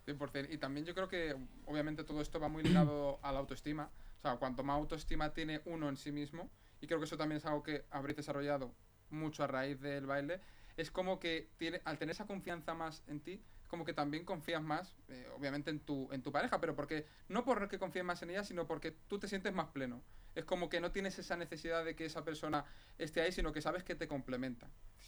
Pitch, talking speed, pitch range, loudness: 155 Hz, 235 wpm, 145-170 Hz, -41 LUFS